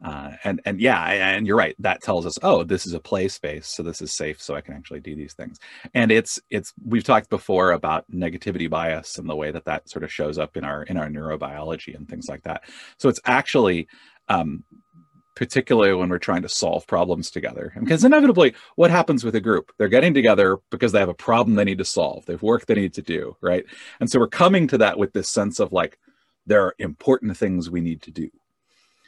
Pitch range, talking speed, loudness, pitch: 80-115 Hz, 230 wpm, -21 LUFS, 95 Hz